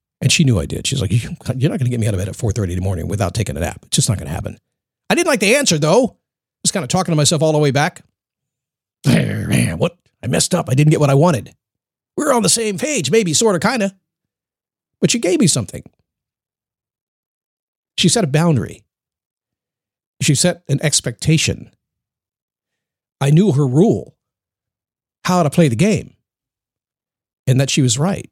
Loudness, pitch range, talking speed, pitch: -16 LUFS, 120-175 Hz, 200 wpm, 145 Hz